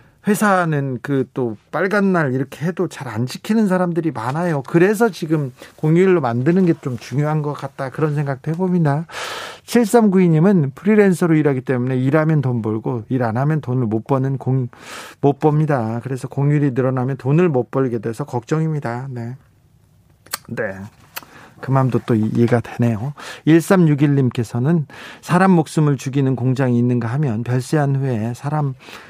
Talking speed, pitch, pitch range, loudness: 305 characters per minute, 140 Hz, 125-165 Hz, -18 LUFS